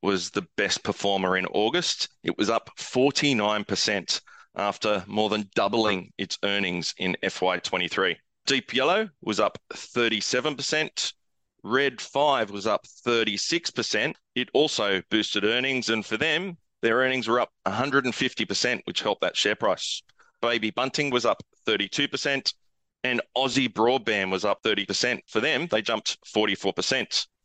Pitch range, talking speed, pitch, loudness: 100-130 Hz, 135 wpm, 110 Hz, -25 LUFS